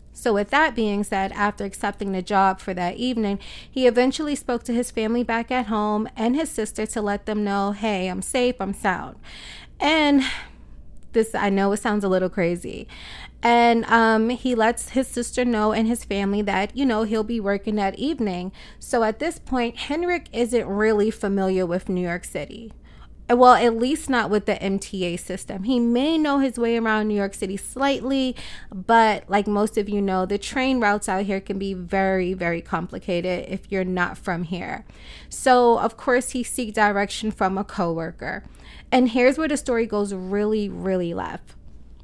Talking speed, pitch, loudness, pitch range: 185 wpm, 215 Hz, -22 LUFS, 195-240 Hz